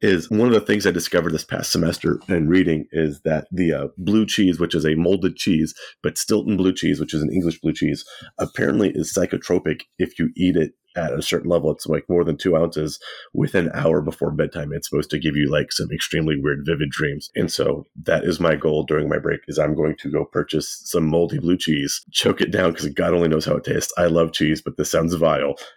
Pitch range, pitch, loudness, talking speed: 75-90 Hz, 85 Hz, -21 LUFS, 240 wpm